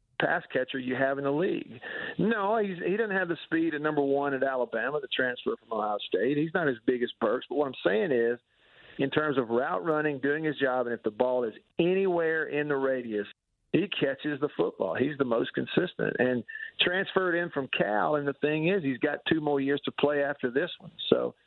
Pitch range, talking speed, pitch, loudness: 130-160 Hz, 225 wpm, 145 Hz, -29 LUFS